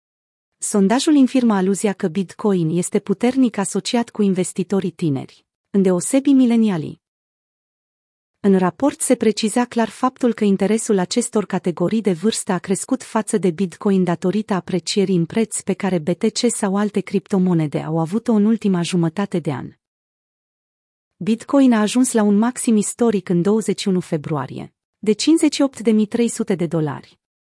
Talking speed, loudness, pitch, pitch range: 135 wpm, -19 LUFS, 205 Hz, 185-225 Hz